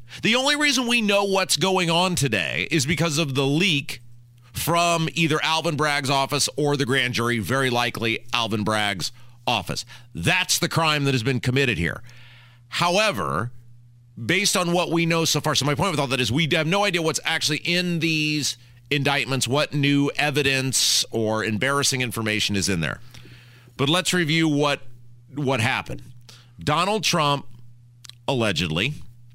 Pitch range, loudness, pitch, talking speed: 120-165 Hz, -21 LUFS, 140 Hz, 160 wpm